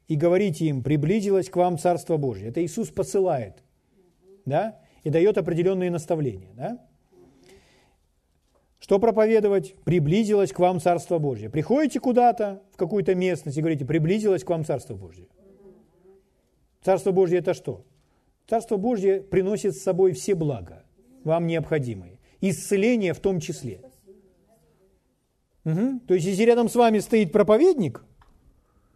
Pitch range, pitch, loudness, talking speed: 160-200 Hz, 185 Hz, -23 LUFS, 130 wpm